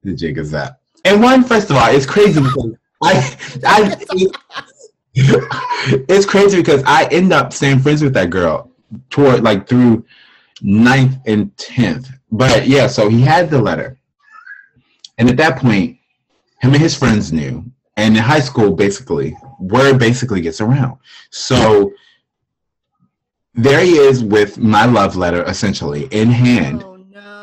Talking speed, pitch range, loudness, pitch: 145 wpm, 110-155 Hz, -12 LUFS, 130 Hz